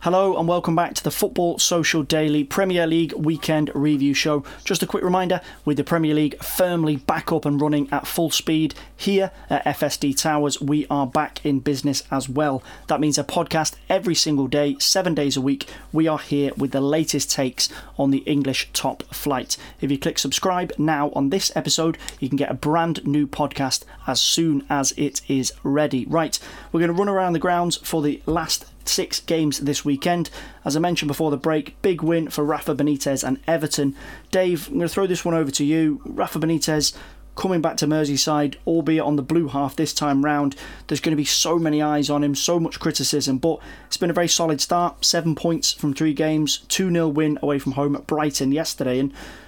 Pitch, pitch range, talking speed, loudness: 150 Hz, 145-165 Hz, 205 wpm, -21 LUFS